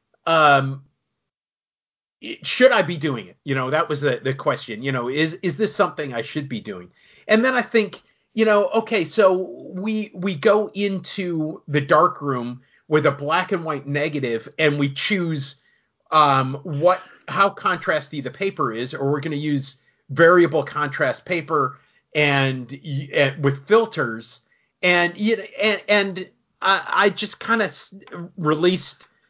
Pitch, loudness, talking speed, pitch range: 155 Hz, -20 LUFS, 160 wpm, 140-195 Hz